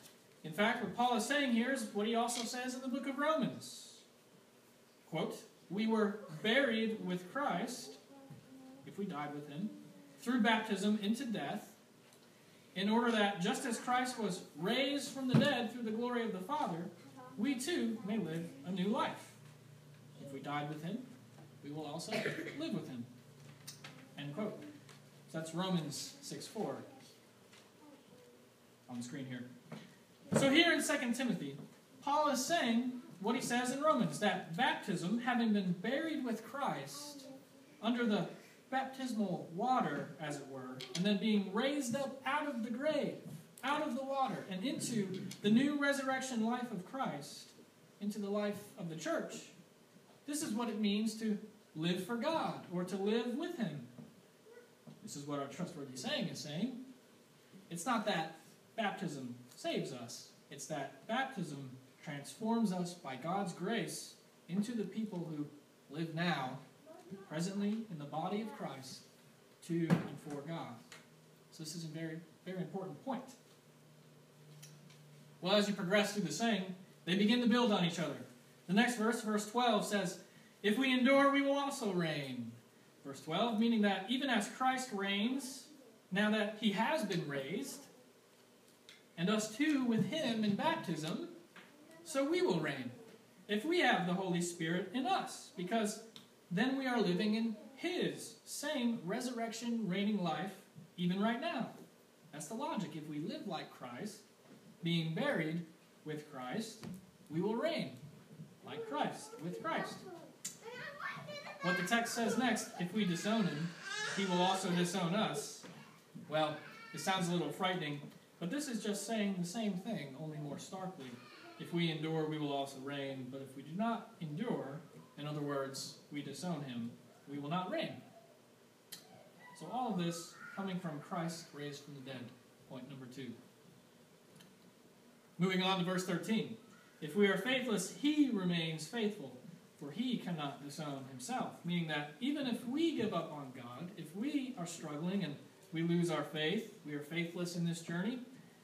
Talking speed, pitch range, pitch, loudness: 160 wpm, 160-230 Hz, 200 Hz, -38 LUFS